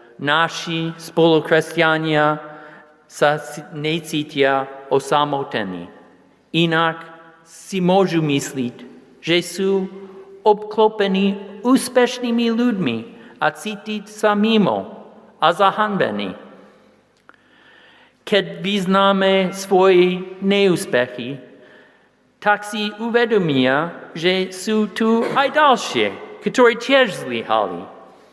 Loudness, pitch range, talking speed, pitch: -18 LUFS, 150-210 Hz, 75 wpm, 185 Hz